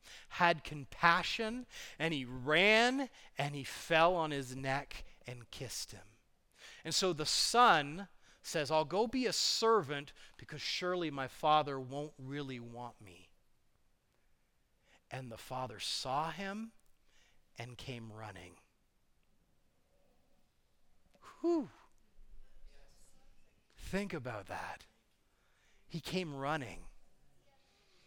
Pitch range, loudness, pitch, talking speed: 125-180 Hz, -34 LUFS, 145 Hz, 100 wpm